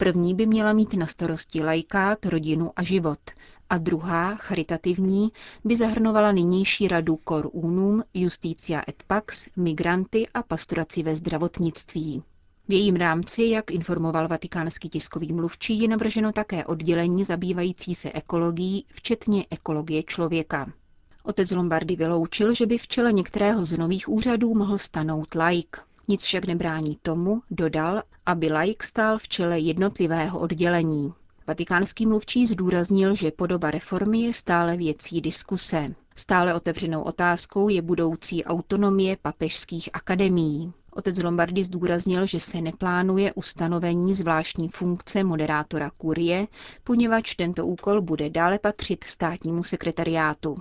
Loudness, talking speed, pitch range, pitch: -24 LUFS, 130 wpm, 165-195 Hz, 175 Hz